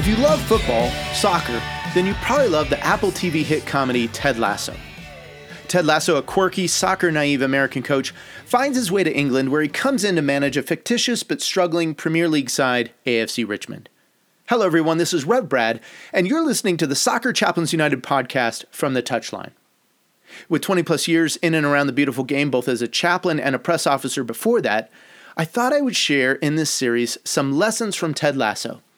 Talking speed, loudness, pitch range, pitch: 195 wpm, -20 LUFS, 135-185 Hz, 155 Hz